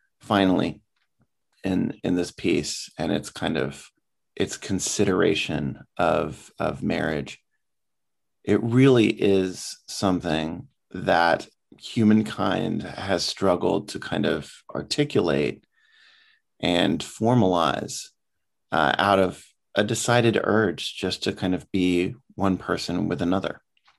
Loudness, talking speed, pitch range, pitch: -24 LUFS, 110 wpm, 90-115 Hz, 100 Hz